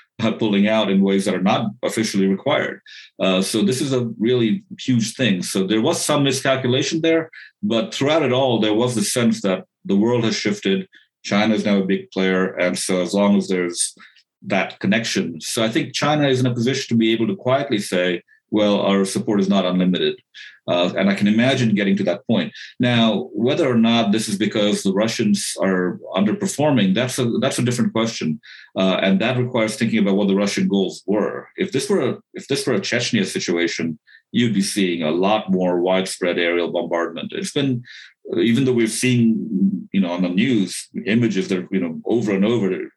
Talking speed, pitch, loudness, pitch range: 200 wpm, 110 Hz, -19 LUFS, 95-125 Hz